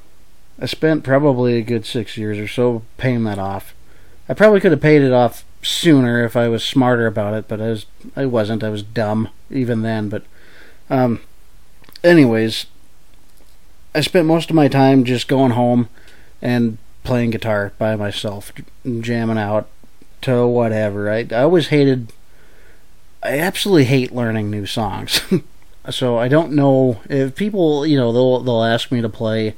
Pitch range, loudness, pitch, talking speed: 110-135 Hz, -17 LUFS, 120 Hz, 165 wpm